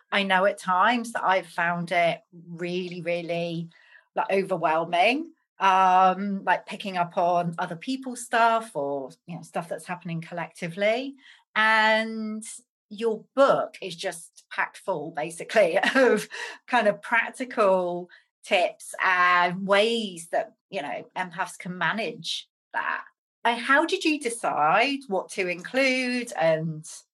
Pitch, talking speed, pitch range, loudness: 190 Hz, 130 wpm, 175-230 Hz, -25 LUFS